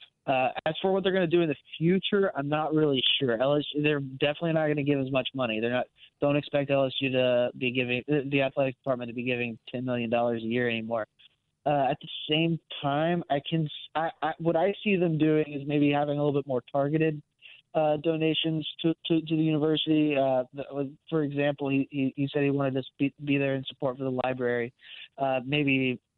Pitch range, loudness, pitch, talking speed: 130-155 Hz, -28 LUFS, 140 Hz, 210 wpm